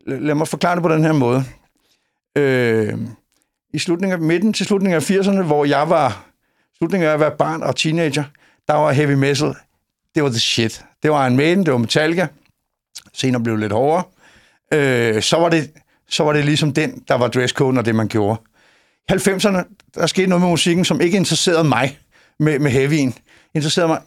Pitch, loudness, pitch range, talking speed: 150 Hz, -17 LUFS, 130-170 Hz, 195 wpm